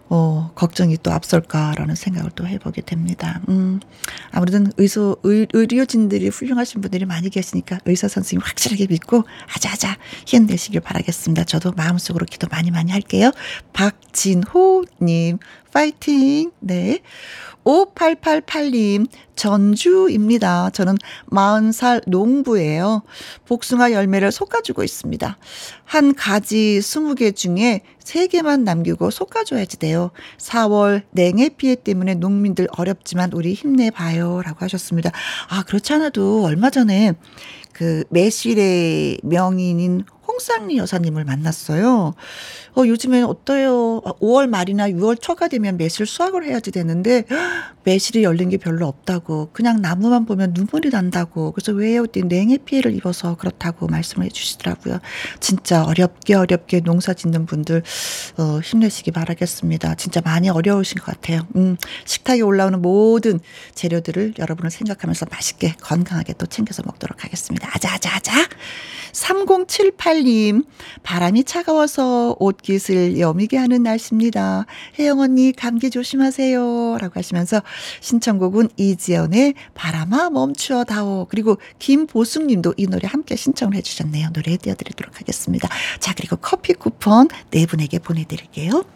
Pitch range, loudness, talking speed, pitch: 175-245 Hz, -18 LUFS, 320 characters per minute, 200 Hz